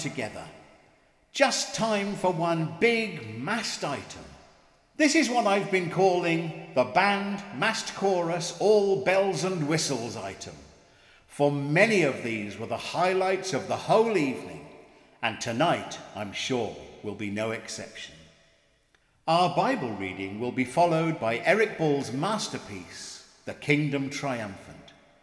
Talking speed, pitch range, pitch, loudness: 130 wpm, 115-195 Hz, 165 Hz, -27 LUFS